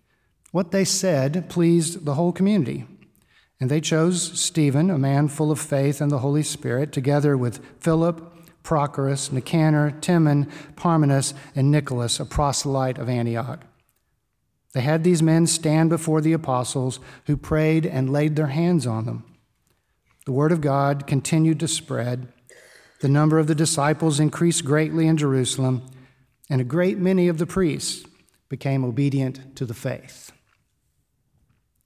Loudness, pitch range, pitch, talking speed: -22 LUFS, 130-160 Hz, 145 Hz, 145 wpm